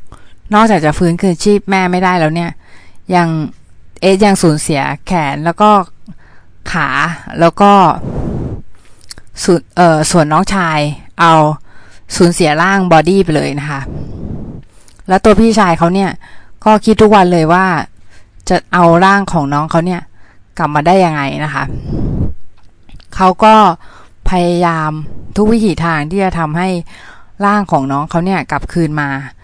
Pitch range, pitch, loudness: 140-190 Hz, 170 Hz, -11 LUFS